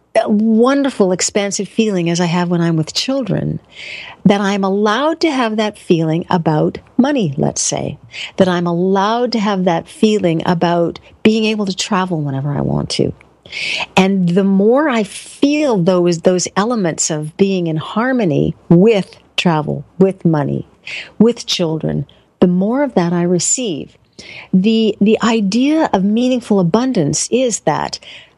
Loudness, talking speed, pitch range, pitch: -15 LUFS, 145 wpm, 175-225 Hz, 195 Hz